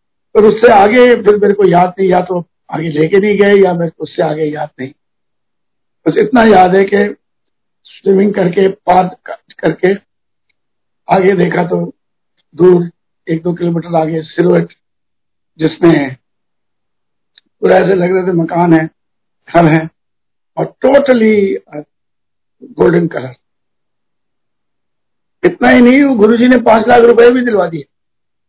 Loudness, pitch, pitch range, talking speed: -10 LUFS, 180 Hz, 160-205 Hz, 135 wpm